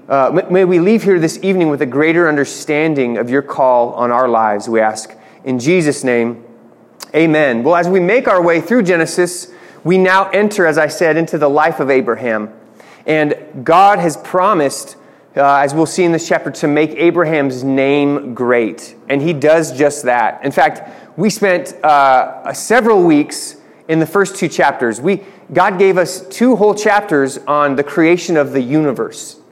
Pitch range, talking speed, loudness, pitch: 135-180 Hz, 180 wpm, -13 LUFS, 155 Hz